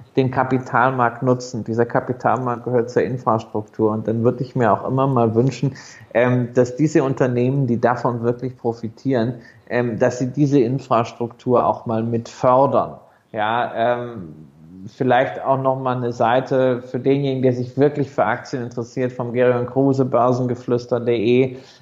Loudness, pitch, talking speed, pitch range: -20 LUFS, 125 Hz, 135 wpm, 120-130 Hz